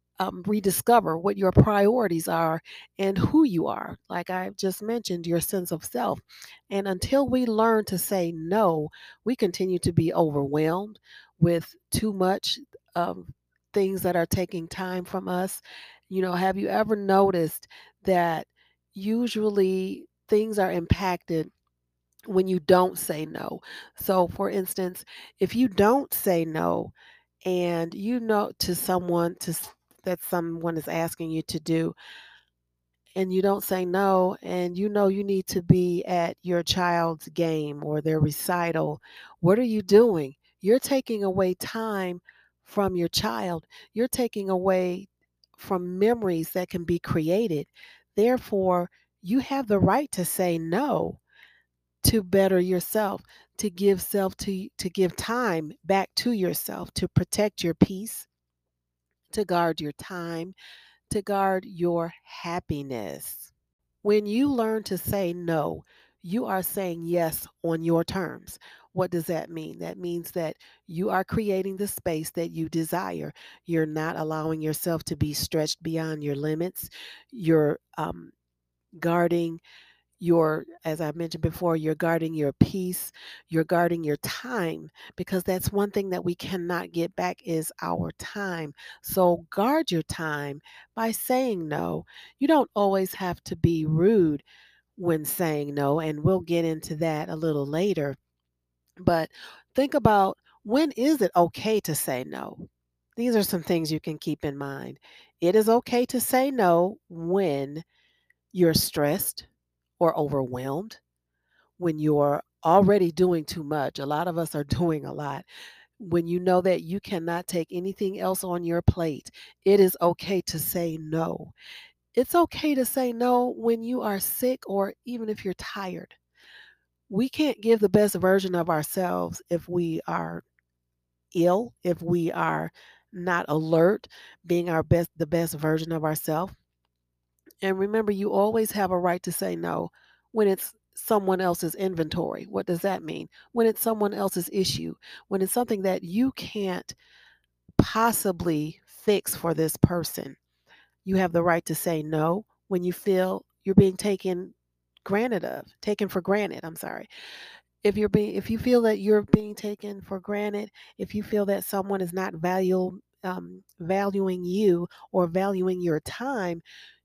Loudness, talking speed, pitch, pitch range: -26 LUFS, 155 wpm, 180 Hz, 160-200 Hz